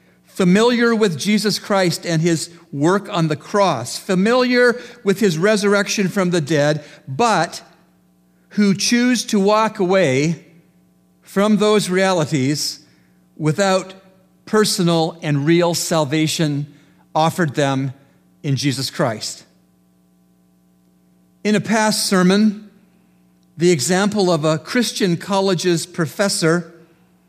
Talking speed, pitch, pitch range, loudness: 105 wpm, 170 Hz, 140-200 Hz, -17 LUFS